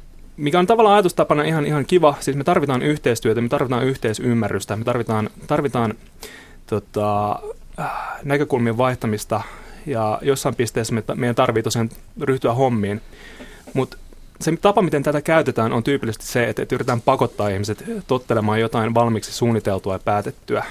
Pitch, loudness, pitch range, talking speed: 125 Hz, -20 LUFS, 110-145 Hz, 140 wpm